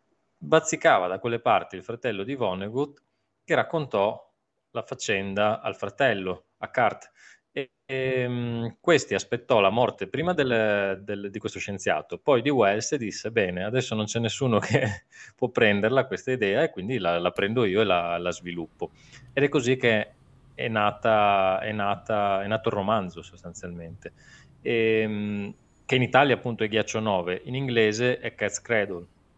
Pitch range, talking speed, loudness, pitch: 95-125 Hz, 160 wpm, -25 LUFS, 110 Hz